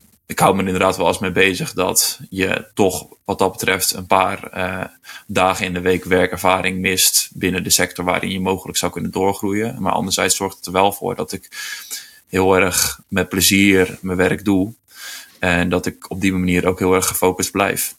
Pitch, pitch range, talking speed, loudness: 95 Hz, 90-100 Hz, 195 wpm, -17 LUFS